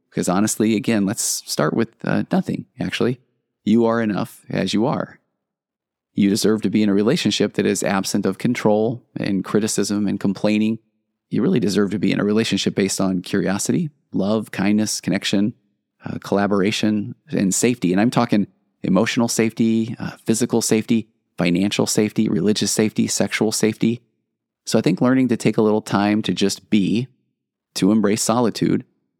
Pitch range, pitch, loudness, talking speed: 100-115 Hz, 110 Hz, -20 LUFS, 160 wpm